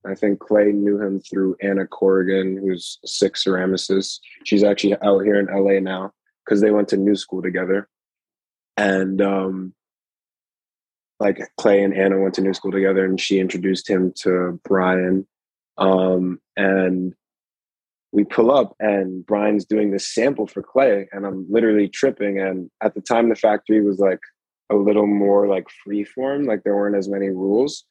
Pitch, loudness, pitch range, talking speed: 100 Hz, -19 LUFS, 95-105 Hz, 170 wpm